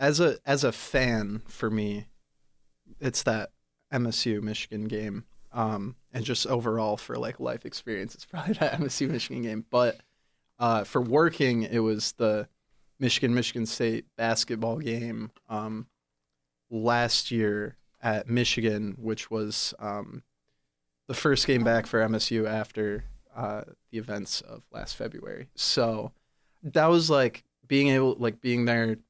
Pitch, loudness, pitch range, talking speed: 115 Hz, -28 LUFS, 105-120 Hz, 140 wpm